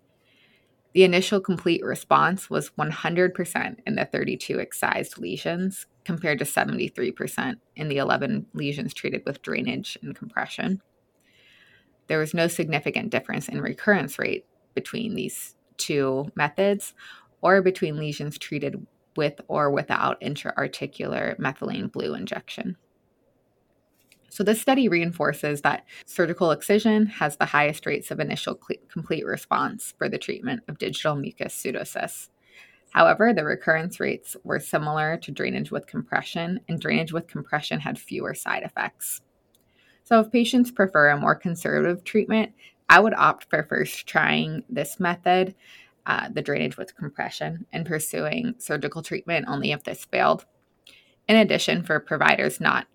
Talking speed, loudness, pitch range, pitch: 135 wpm, -24 LUFS, 150-195 Hz, 175 Hz